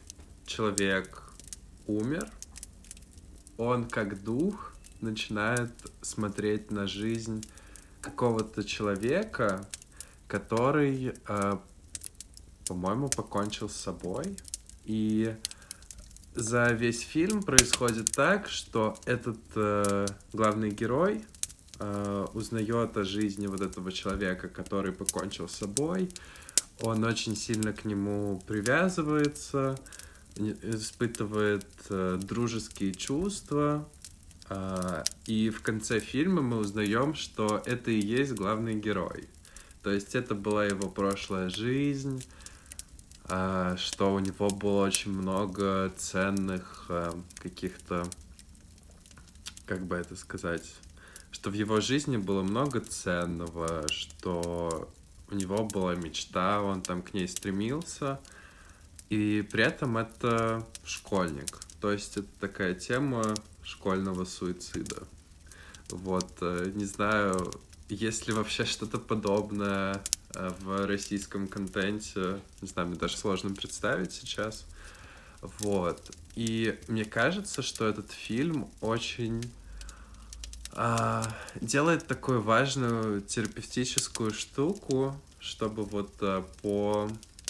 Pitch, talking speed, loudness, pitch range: 100 Hz, 100 wpm, -31 LUFS, 90-110 Hz